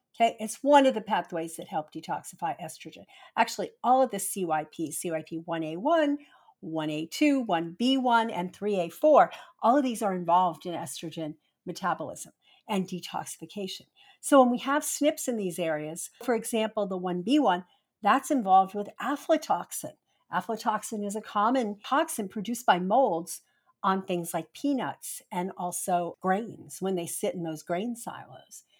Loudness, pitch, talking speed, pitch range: -28 LUFS, 195 Hz, 140 wpm, 170-255 Hz